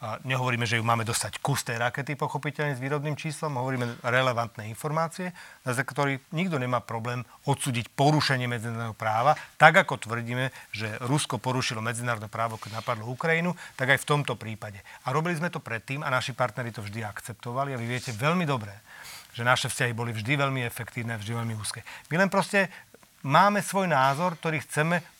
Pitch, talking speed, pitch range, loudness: 130 Hz, 180 wpm, 115-150 Hz, -27 LUFS